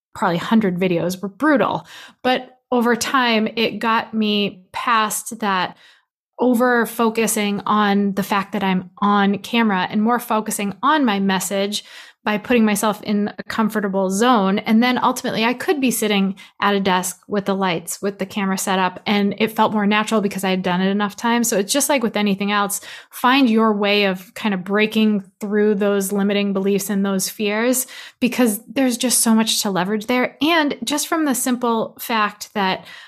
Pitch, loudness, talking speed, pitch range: 210 Hz, -19 LUFS, 185 wpm, 200-235 Hz